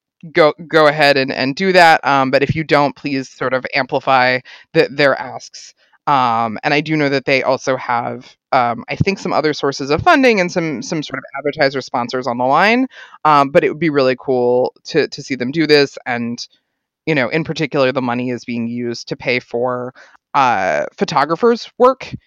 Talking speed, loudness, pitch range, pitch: 200 wpm, -15 LUFS, 130-160 Hz, 140 Hz